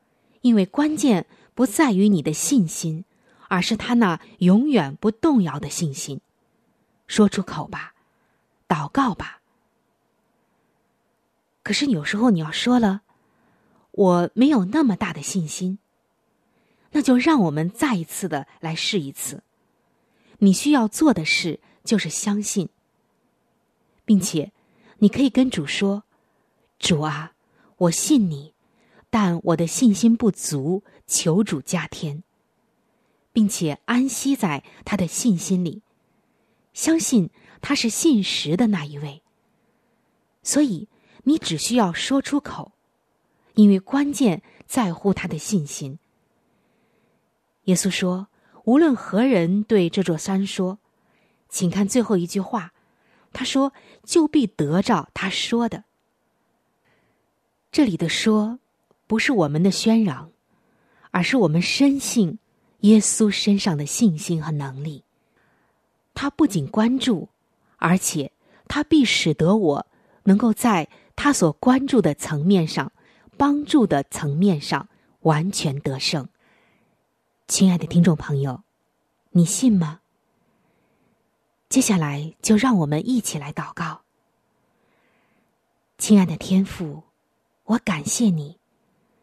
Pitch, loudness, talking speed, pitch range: 210 Hz, -21 LUFS, 170 characters per minute, 175-235 Hz